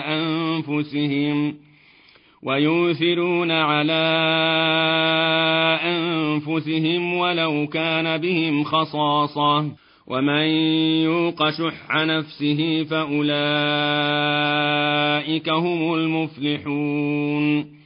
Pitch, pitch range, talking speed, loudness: 155 Hz, 150-160 Hz, 50 wpm, -20 LUFS